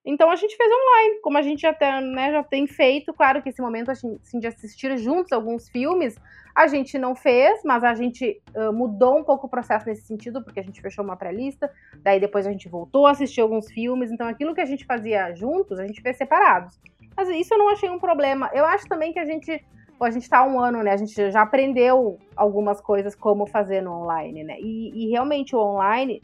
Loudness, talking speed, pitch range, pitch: -21 LUFS, 230 wpm, 215-290 Hz, 250 Hz